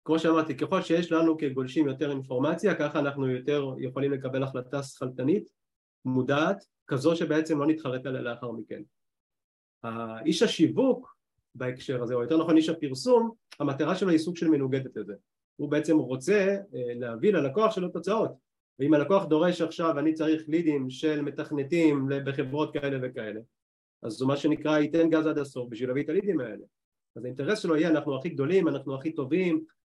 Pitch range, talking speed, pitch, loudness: 130-160 Hz, 165 wpm, 150 Hz, -28 LUFS